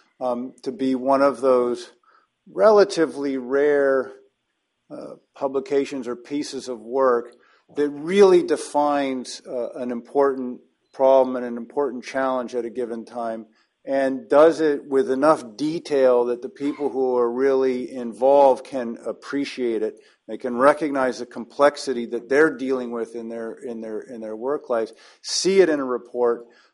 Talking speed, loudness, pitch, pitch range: 150 wpm, -22 LUFS, 130 Hz, 120-140 Hz